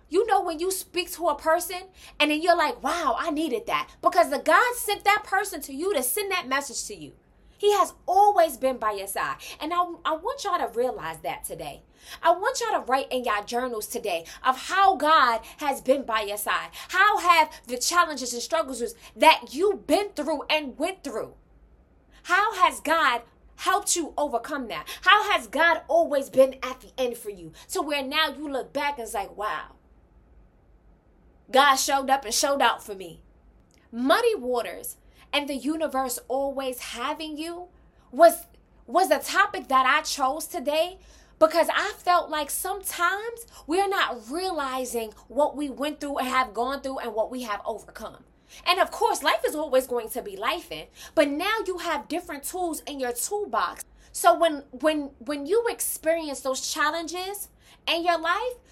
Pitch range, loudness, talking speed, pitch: 260-355 Hz, -25 LUFS, 185 wpm, 310 Hz